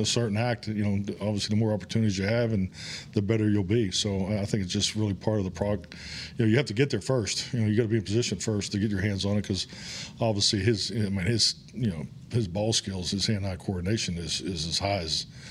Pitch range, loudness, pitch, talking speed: 100-115 Hz, -28 LUFS, 105 Hz, 265 wpm